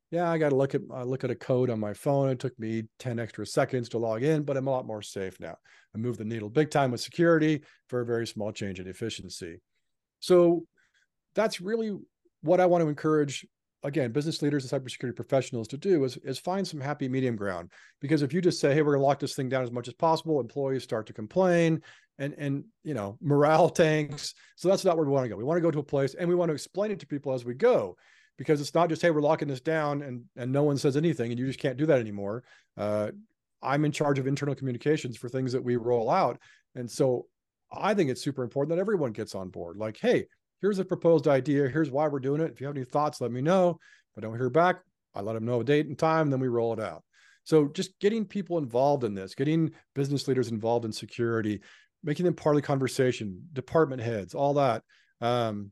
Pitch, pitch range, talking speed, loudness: 140 Hz, 120-160 Hz, 245 wpm, -28 LUFS